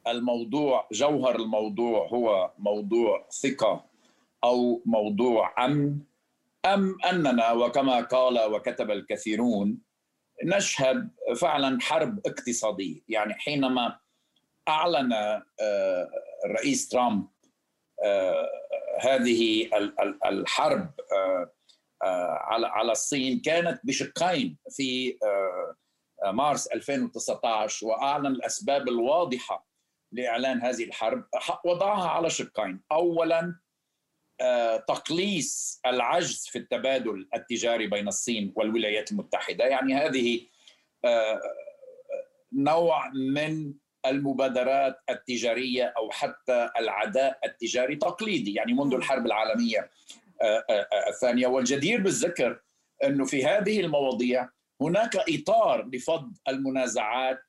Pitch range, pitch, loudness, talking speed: 120-195 Hz, 135 Hz, -27 LUFS, 80 wpm